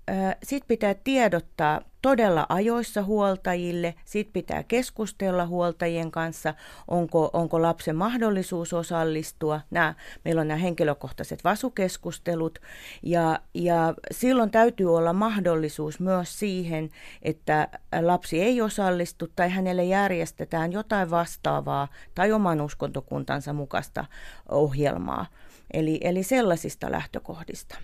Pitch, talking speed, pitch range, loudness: 175 Hz, 105 wpm, 160-200 Hz, -26 LUFS